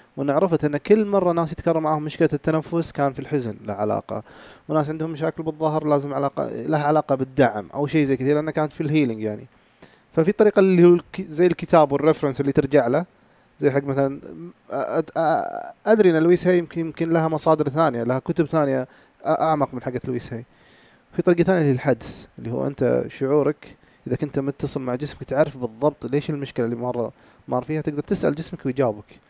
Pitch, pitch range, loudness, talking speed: 150 Hz, 135-165 Hz, -22 LUFS, 180 wpm